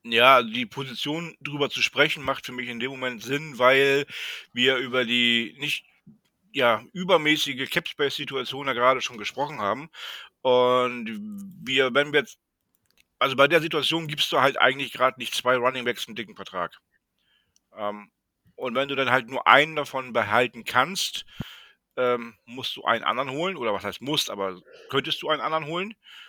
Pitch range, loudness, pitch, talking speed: 125-150 Hz, -24 LUFS, 135 Hz, 165 wpm